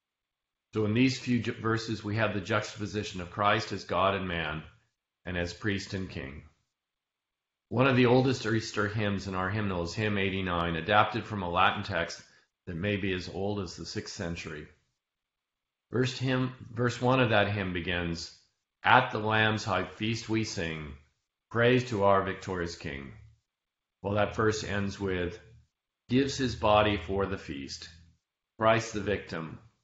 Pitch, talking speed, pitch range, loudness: 100 Hz, 165 wpm, 85-110 Hz, -29 LUFS